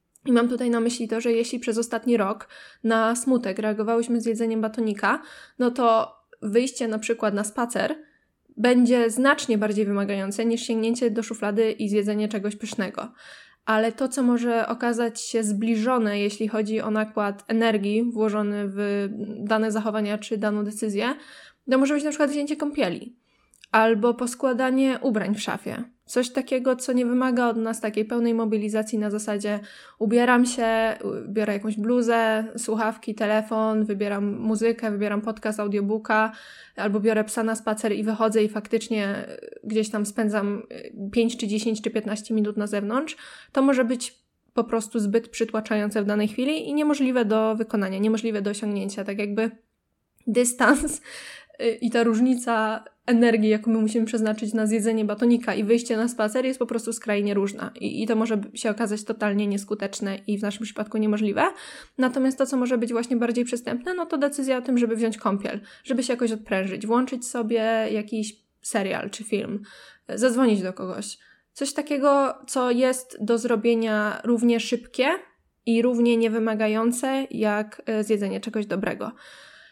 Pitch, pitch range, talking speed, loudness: 225 Hz, 215-245 Hz, 155 wpm, -24 LUFS